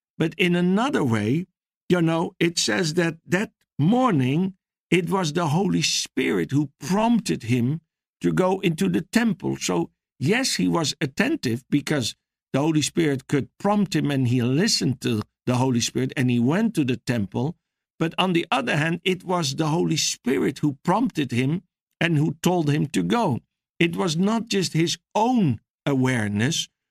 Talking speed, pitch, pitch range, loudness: 165 wpm, 165 Hz, 135-185 Hz, -23 LUFS